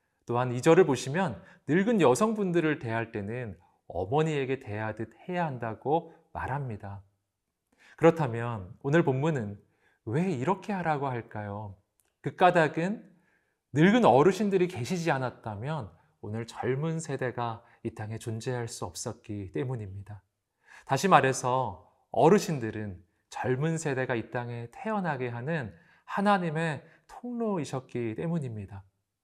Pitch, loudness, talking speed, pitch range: 125 Hz, -29 LUFS, 270 characters per minute, 110-165 Hz